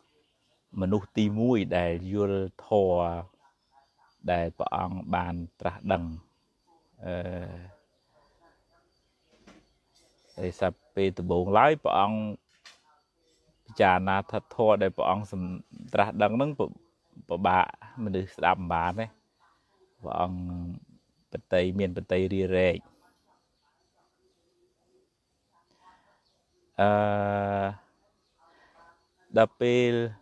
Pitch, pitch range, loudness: 95 Hz, 90-105 Hz, -28 LUFS